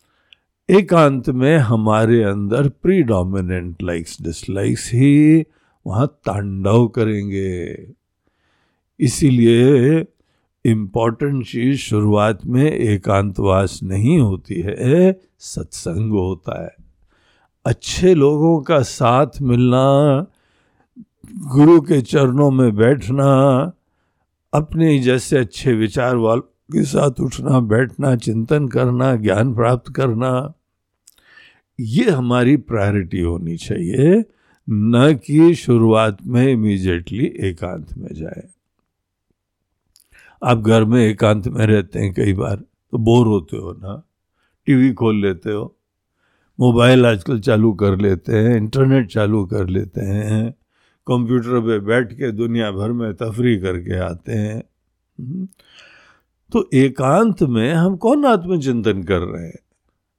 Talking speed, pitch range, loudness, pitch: 110 wpm, 100-135 Hz, -16 LUFS, 115 Hz